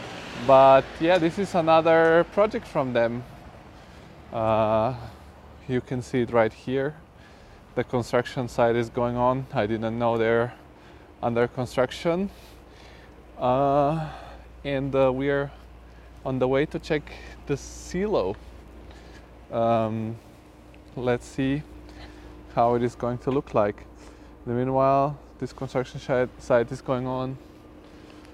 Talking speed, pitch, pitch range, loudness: 120 wpm, 125 Hz, 110-135 Hz, -24 LUFS